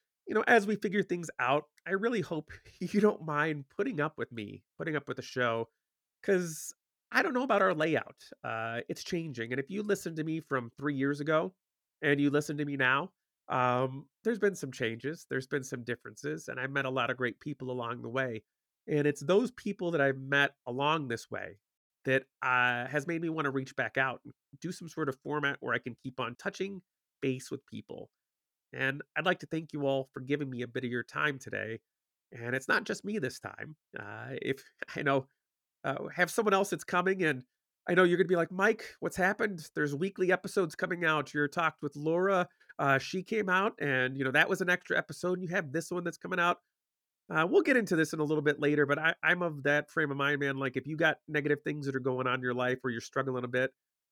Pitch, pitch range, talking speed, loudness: 150 Hz, 130-175 Hz, 235 wpm, -32 LUFS